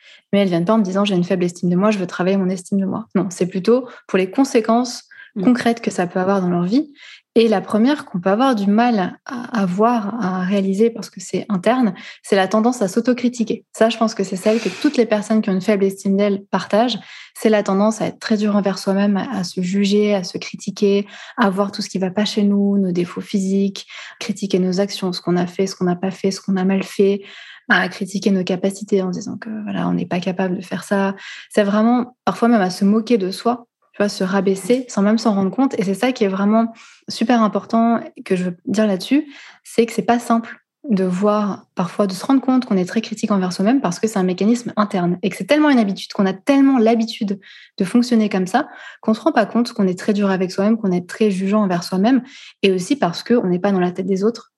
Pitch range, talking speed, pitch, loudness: 190-230 Hz, 255 wpm, 205 Hz, -18 LUFS